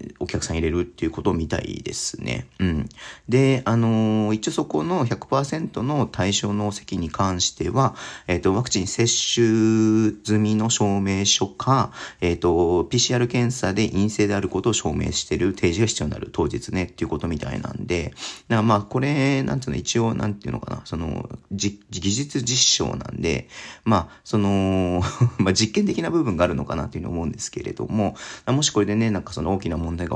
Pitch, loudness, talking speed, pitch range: 105 Hz, -22 LUFS, 360 characters per minute, 95-120 Hz